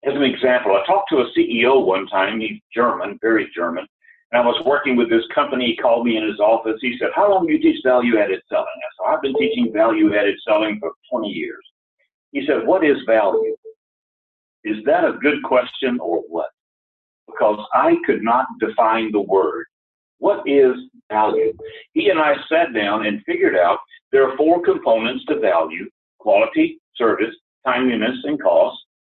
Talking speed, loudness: 180 wpm, -18 LUFS